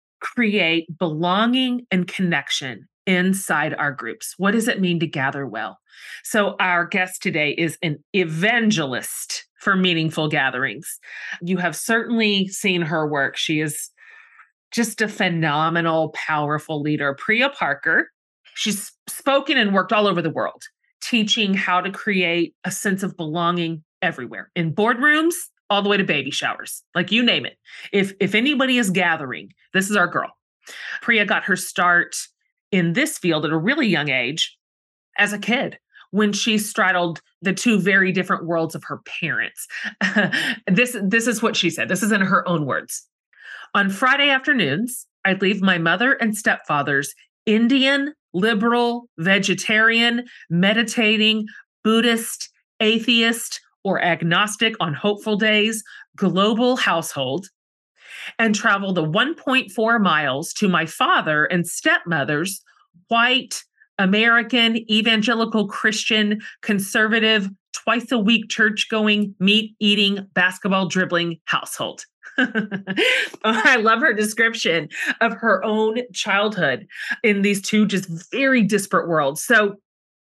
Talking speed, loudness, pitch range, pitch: 135 wpm, -19 LUFS, 175-230 Hz, 205 Hz